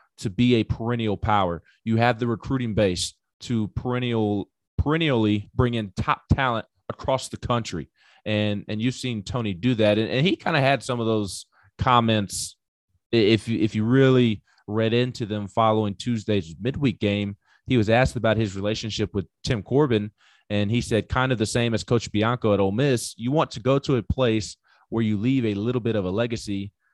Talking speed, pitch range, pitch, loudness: 195 wpm, 105-125 Hz, 115 Hz, -24 LUFS